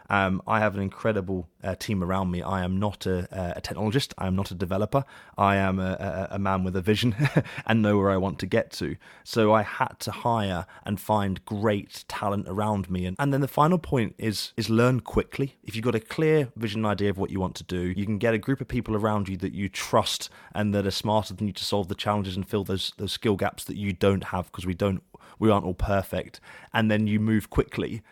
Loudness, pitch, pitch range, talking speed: -27 LUFS, 100 Hz, 95-110 Hz, 245 wpm